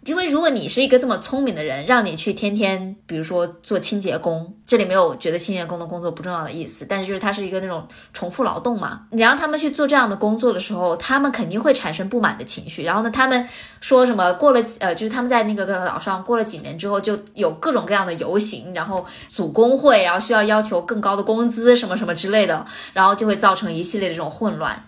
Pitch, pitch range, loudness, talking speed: 205 Hz, 185-240 Hz, -19 LUFS, 380 characters per minute